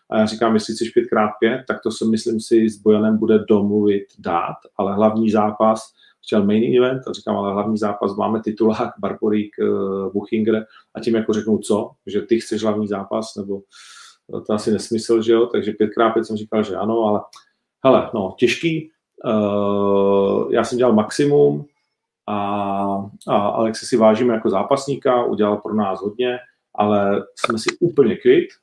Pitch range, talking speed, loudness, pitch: 105-115 Hz, 170 wpm, -19 LUFS, 110 Hz